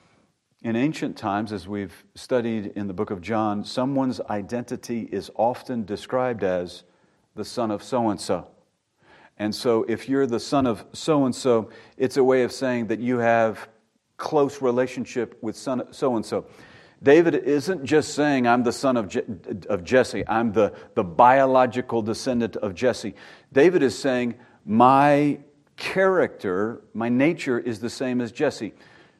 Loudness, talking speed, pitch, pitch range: -23 LUFS, 150 wpm, 120 Hz, 110-130 Hz